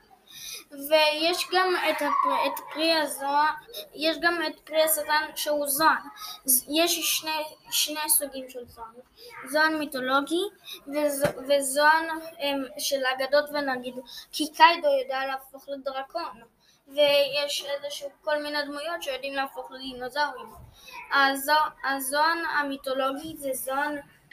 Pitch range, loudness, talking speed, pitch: 275-315 Hz, -25 LUFS, 100 wpm, 295 Hz